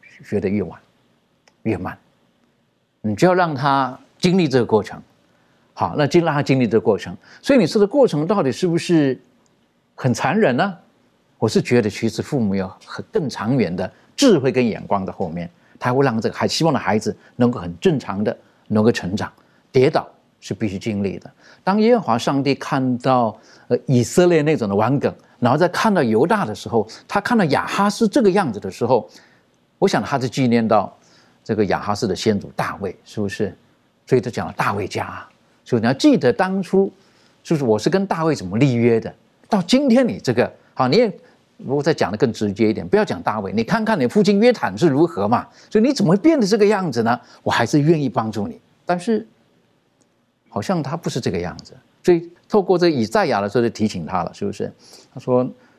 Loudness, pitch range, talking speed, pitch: -19 LUFS, 115-195 Hz, 295 characters per minute, 140 Hz